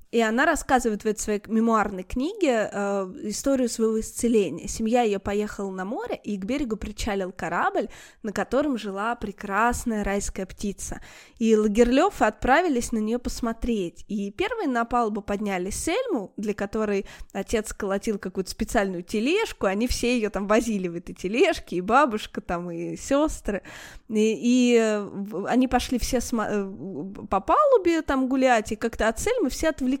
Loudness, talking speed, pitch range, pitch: -25 LUFS, 150 wpm, 205-250 Hz, 225 Hz